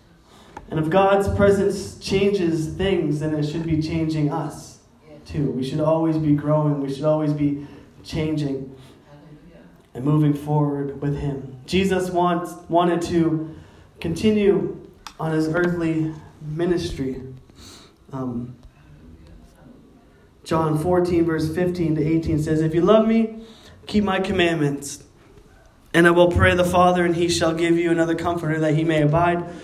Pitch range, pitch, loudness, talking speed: 145-175 Hz, 160 Hz, -21 LUFS, 140 wpm